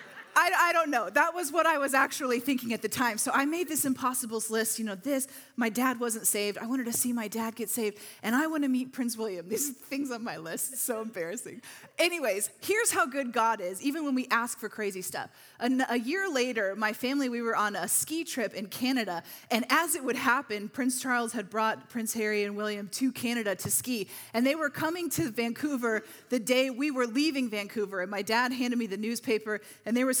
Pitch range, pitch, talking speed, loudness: 220-275 Hz, 245 Hz, 230 wpm, -29 LUFS